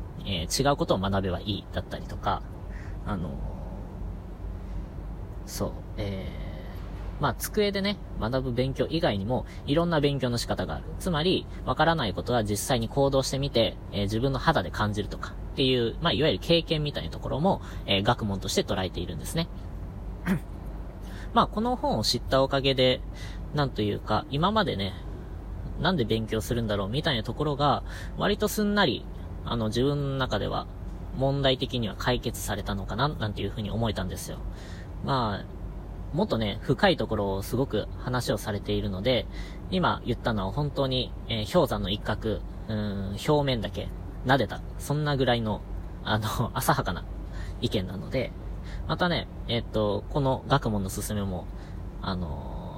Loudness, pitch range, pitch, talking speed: -28 LUFS, 95-130 Hz, 105 Hz, 325 characters per minute